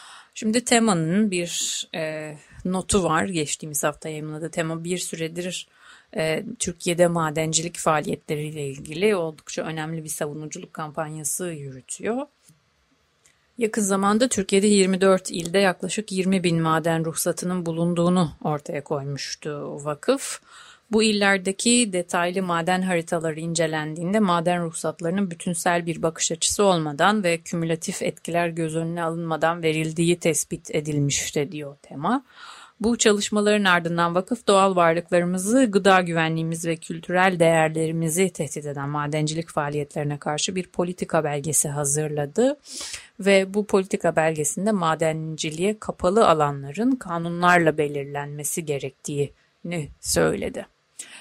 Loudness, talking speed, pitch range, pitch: -23 LUFS, 110 wpm, 155-195 Hz, 170 Hz